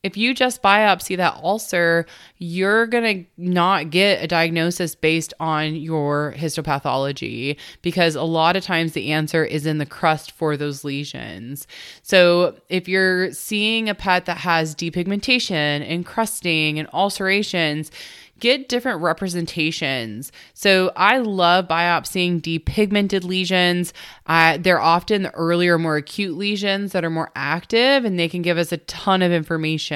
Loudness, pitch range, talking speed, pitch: -19 LUFS, 160-195 Hz, 150 wpm, 175 Hz